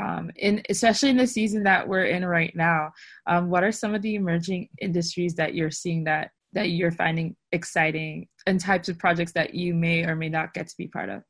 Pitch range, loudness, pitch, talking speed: 165-195 Hz, -25 LUFS, 175 Hz, 225 wpm